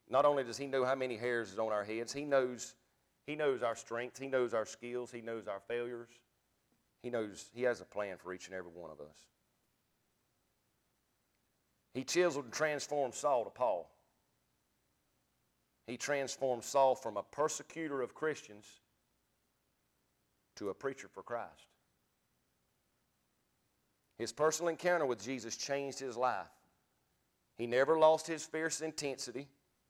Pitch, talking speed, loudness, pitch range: 125 Hz, 145 wpm, -37 LUFS, 110-145 Hz